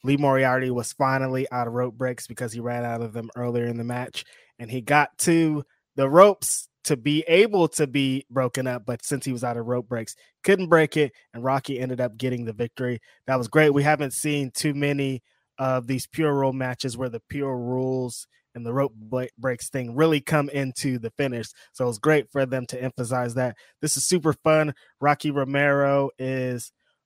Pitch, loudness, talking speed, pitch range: 130 Hz, -24 LUFS, 205 wpm, 125-145 Hz